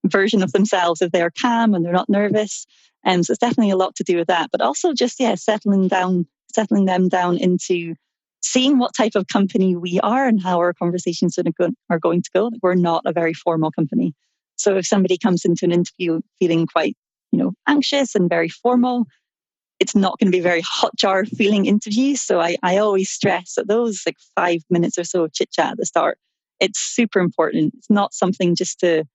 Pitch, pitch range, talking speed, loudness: 185 Hz, 175-220 Hz, 215 wpm, -19 LUFS